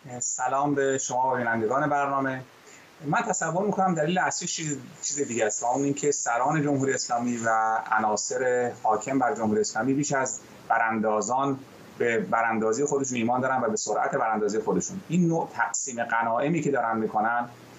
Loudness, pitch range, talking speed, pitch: -26 LUFS, 115-145 Hz, 150 wpm, 130 Hz